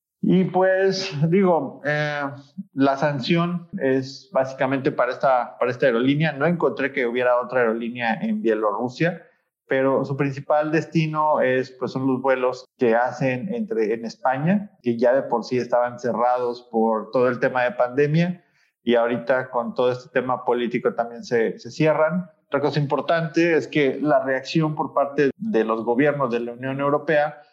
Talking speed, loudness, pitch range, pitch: 165 wpm, -22 LUFS, 125-160 Hz, 140 Hz